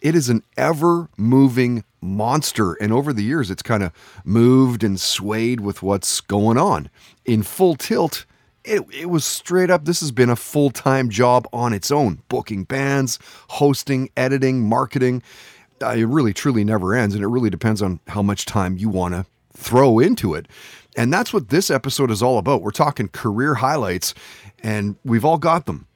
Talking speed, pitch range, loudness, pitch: 185 wpm, 105-140 Hz, -19 LUFS, 120 Hz